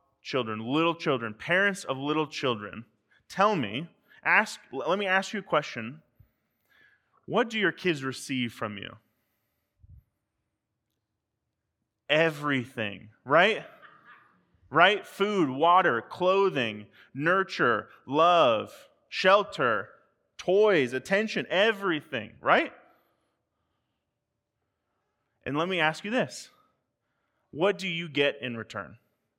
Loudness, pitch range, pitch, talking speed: -26 LUFS, 115-190 Hz, 150 Hz, 100 wpm